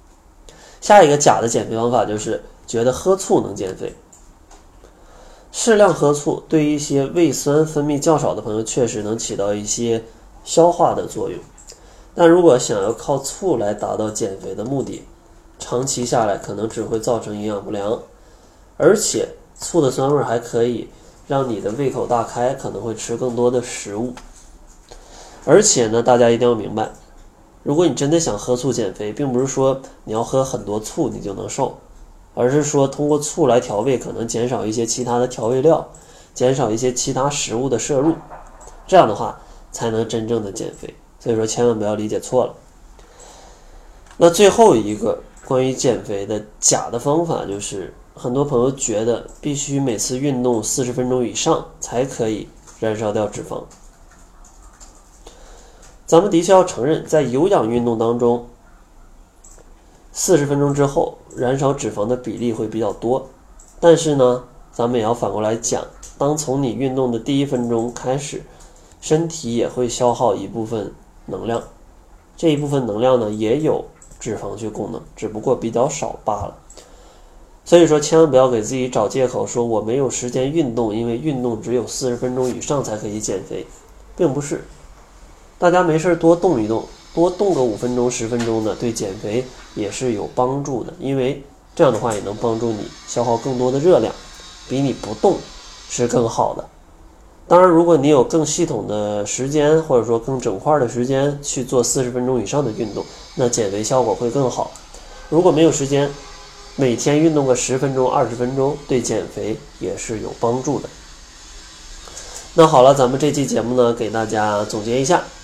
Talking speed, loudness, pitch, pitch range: 260 characters per minute, -18 LUFS, 125 Hz, 115-145 Hz